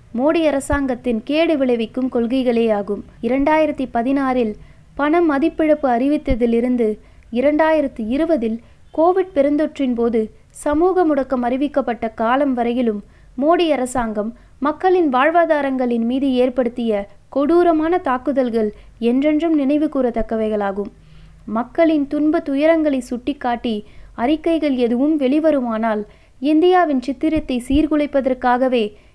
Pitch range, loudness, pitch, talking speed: 240-305 Hz, -18 LUFS, 265 Hz, 85 wpm